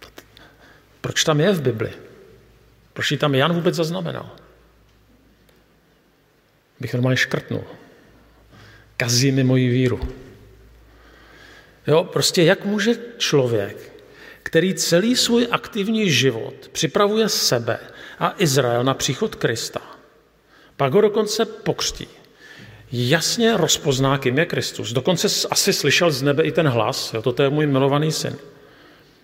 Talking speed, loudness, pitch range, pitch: 120 wpm, -19 LUFS, 130-205 Hz, 155 Hz